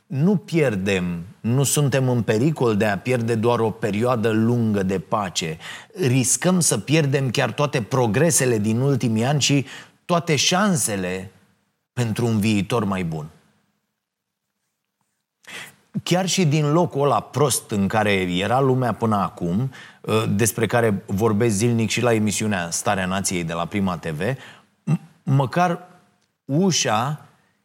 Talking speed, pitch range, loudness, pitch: 130 wpm, 105-145 Hz, -21 LUFS, 120 Hz